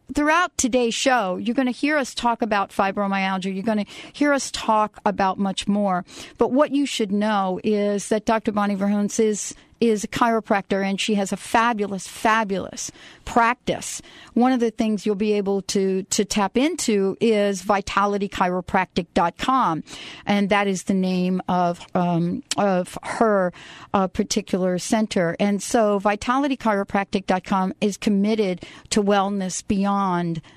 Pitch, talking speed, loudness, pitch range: 205 Hz, 145 wpm, -22 LUFS, 195-225 Hz